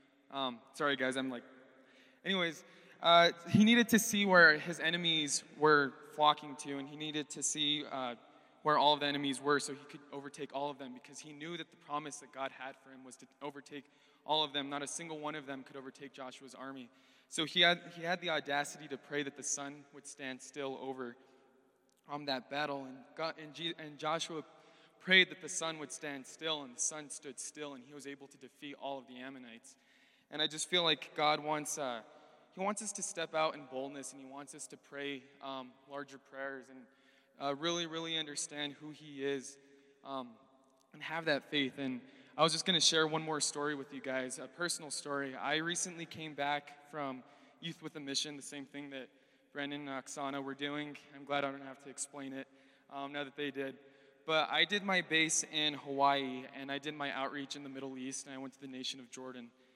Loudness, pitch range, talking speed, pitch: -35 LUFS, 135-155 Hz, 220 wpm, 145 Hz